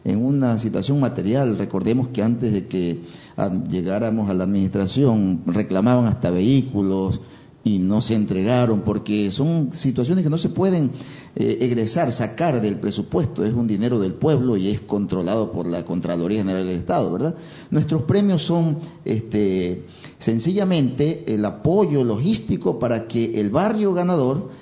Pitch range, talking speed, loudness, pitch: 100-140 Hz, 145 wpm, -21 LUFS, 115 Hz